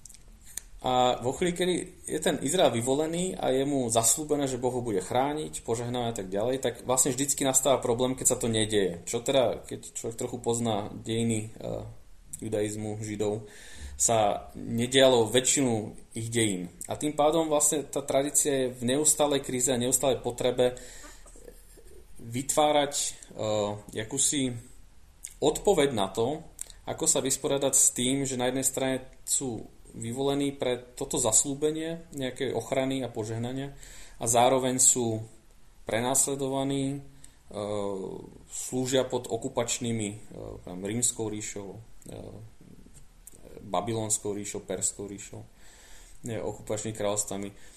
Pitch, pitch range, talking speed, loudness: 125 Hz, 110-135 Hz, 125 wpm, -27 LUFS